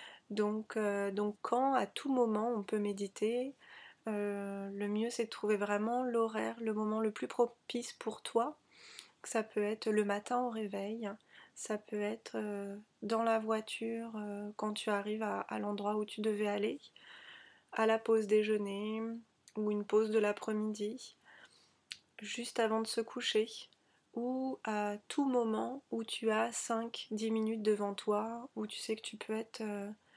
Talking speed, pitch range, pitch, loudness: 165 wpm, 210-230 Hz, 220 Hz, -36 LUFS